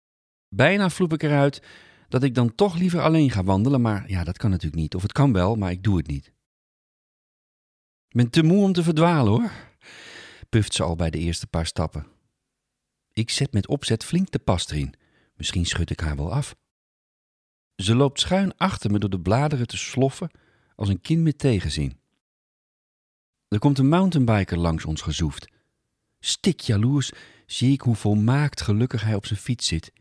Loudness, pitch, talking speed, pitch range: -23 LUFS, 110 Hz, 180 wpm, 90-140 Hz